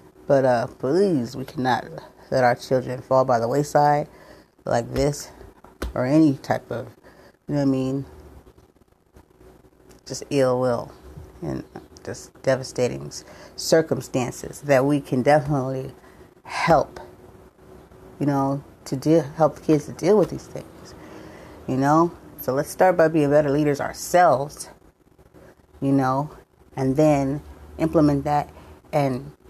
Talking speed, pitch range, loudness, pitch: 130 wpm, 125-150 Hz, -22 LUFS, 140 Hz